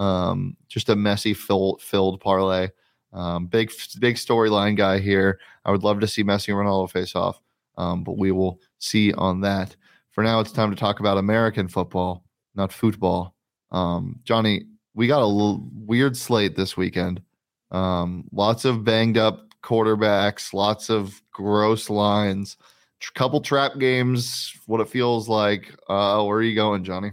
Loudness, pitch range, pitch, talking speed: -22 LUFS, 95-110 Hz, 105 Hz, 165 wpm